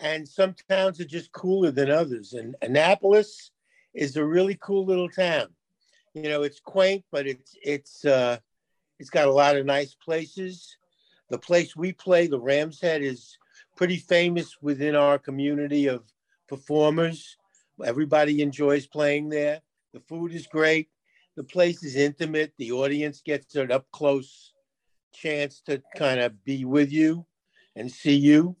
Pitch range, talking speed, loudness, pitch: 140-175 Hz, 155 wpm, -24 LUFS, 150 Hz